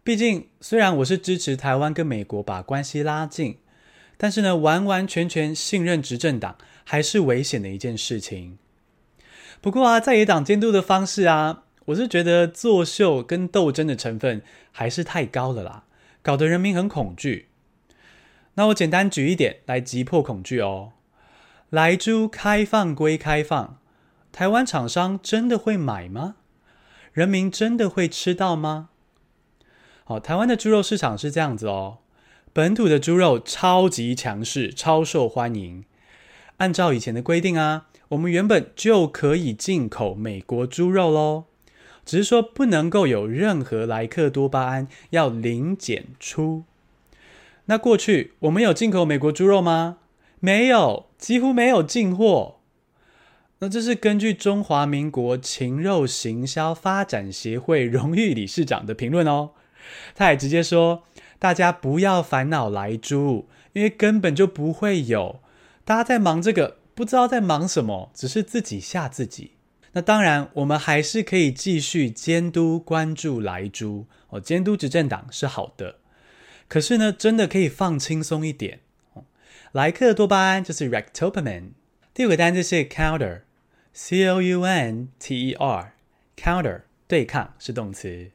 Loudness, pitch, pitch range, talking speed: -21 LUFS, 160 Hz, 130-190 Hz, 240 characters per minute